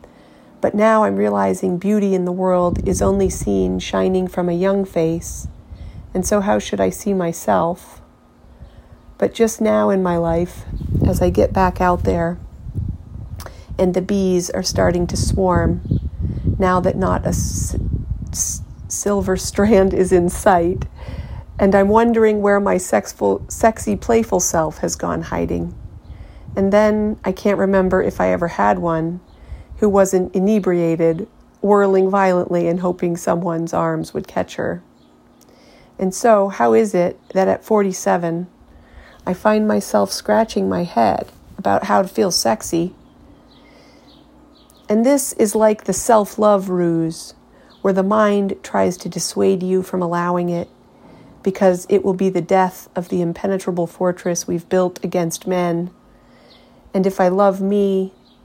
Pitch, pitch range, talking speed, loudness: 185 Hz, 165-200 Hz, 145 wpm, -18 LUFS